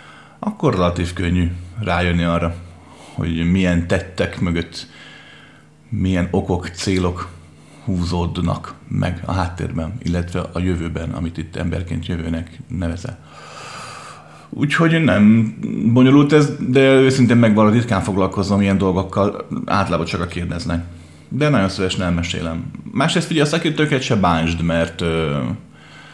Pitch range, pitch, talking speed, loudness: 85-110 Hz, 90 Hz, 115 wpm, -18 LUFS